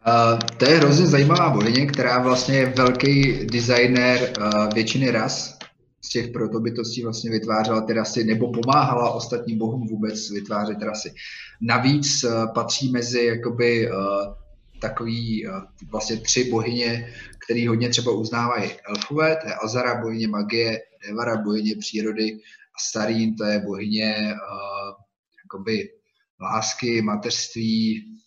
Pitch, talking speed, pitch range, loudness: 115 Hz, 130 wpm, 110-125 Hz, -22 LUFS